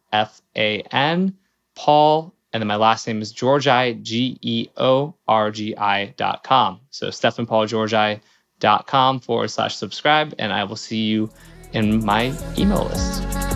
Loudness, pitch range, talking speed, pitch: -20 LUFS, 105-130 Hz, 155 wpm, 110 Hz